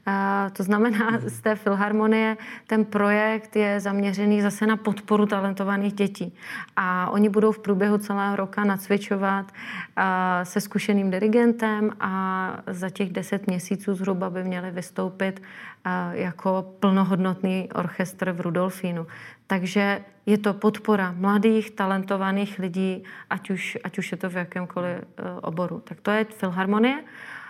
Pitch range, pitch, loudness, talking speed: 185-210 Hz, 200 Hz, -25 LUFS, 130 wpm